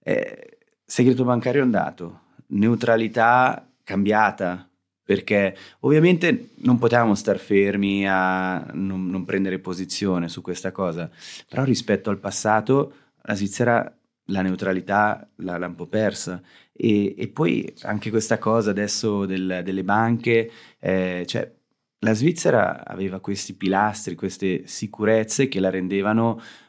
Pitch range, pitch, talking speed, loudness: 95-115 Hz, 100 Hz, 120 wpm, -22 LUFS